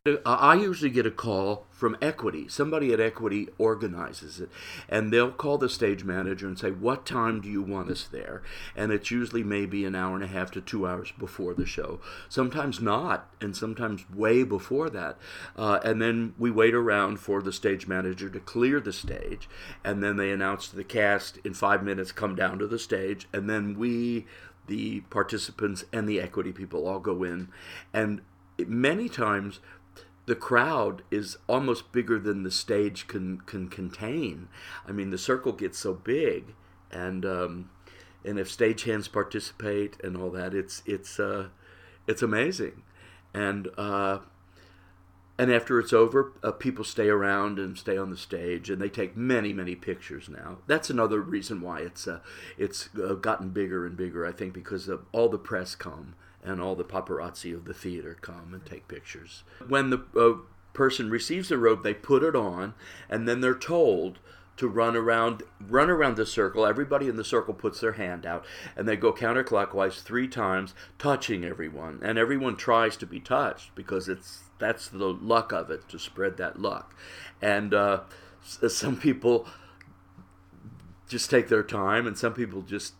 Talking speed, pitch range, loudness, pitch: 175 wpm, 95-115 Hz, -28 LUFS, 100 Hz